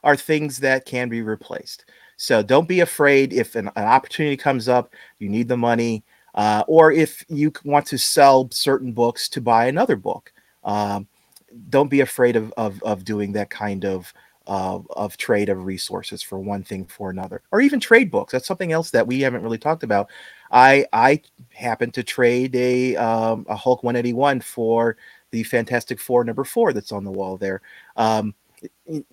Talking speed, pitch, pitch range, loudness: 185 wpm, 120 Hz, 105-140 Hz, -20 LUFS